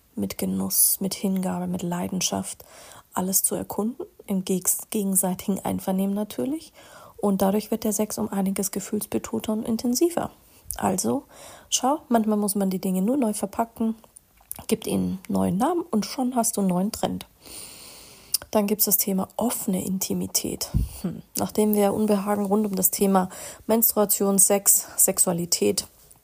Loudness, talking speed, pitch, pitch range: -23 LUFS, 140 wpm, 205 Hz, 190-225 Hz